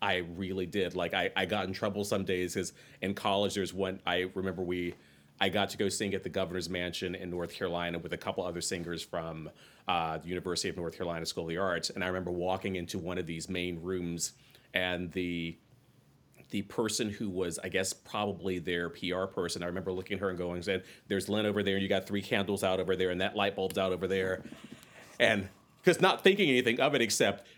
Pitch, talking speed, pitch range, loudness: 95 Hz, 225 wpm, 90-100 Hz, -32 LUFS